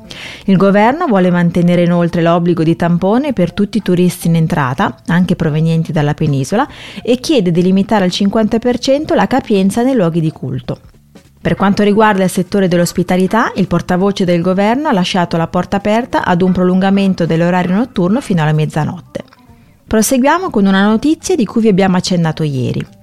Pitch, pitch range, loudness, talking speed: 185 Hz, 170-215 Hz, -13 LUFS, 165 wpm